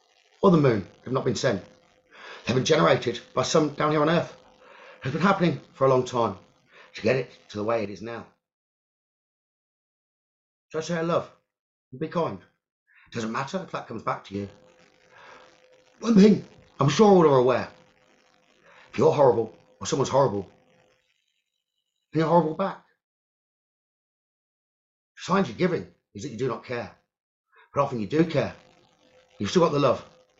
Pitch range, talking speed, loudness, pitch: 115-165 Hz, 165 wpm, -24 LUFS, 140 Hz